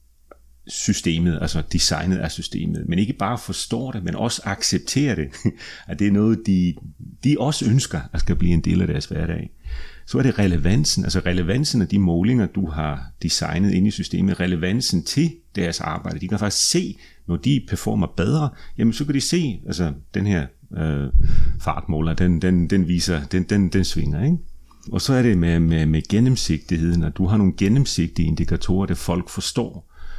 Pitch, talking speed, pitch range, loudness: 95 Hz, 185 wpm, 85-115 Hz, -21 LUFS